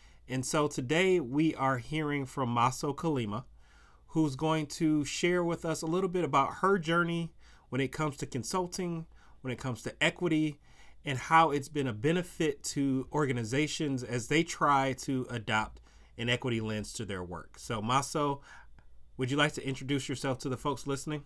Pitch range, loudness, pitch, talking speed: 130-160 Hz, -31 LUFS, 145 Hz, 175 wpm